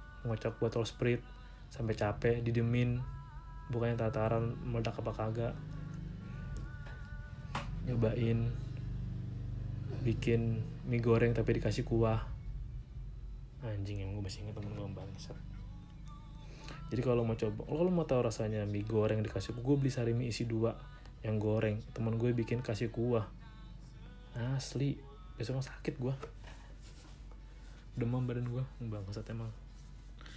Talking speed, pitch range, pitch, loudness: 120 wpm, 110-125 Hz, 115 Hz, -36 LUFS